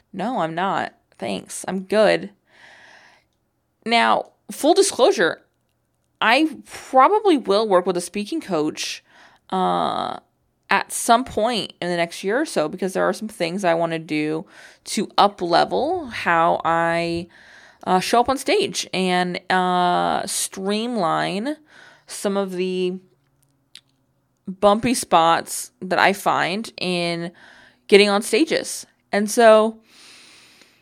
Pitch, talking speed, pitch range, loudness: 190 Hz, 125 wpm, 170-225 Hz, -20 LUFS